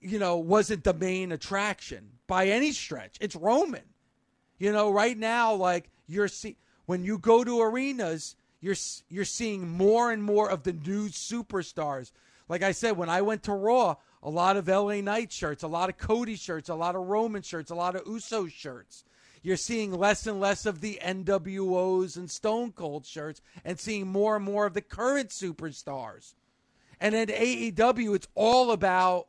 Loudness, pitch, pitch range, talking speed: -28 LUFS, 195 Hz, 175-215 Hz, 185 wpm